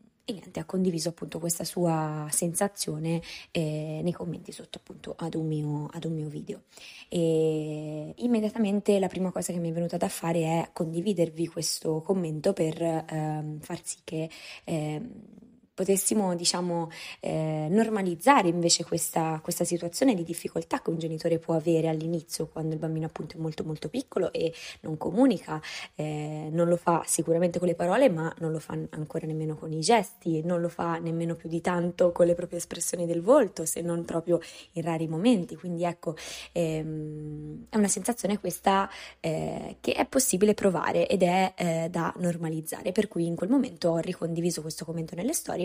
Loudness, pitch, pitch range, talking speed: -28 LUFS, 170 Hz, 160-185 Hz, 170 wpm